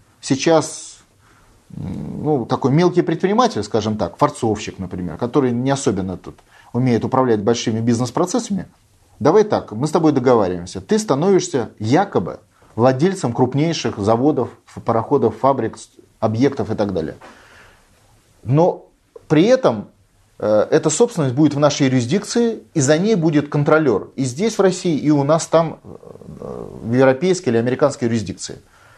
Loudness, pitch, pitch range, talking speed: -18 LUFS, 135 Hz, 110-160 Hz, 130 wpm